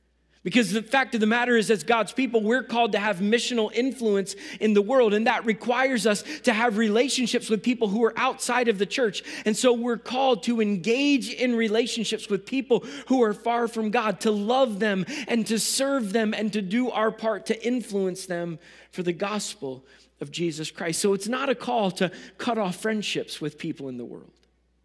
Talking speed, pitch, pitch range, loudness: 205 wpm, 225 Hz, 205-245 Hz, -24 LUFS